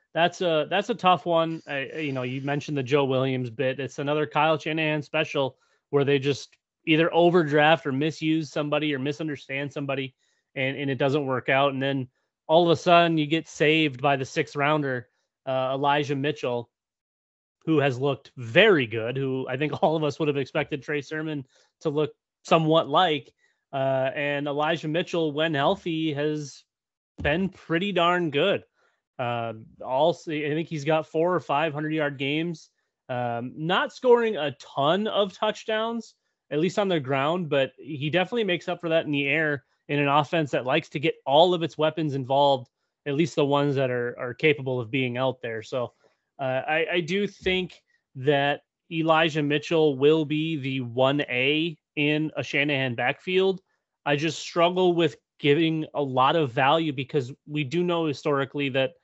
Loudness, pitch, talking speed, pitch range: -25 LUFS, 150 Hz, 180 wpm, 140-165 Hz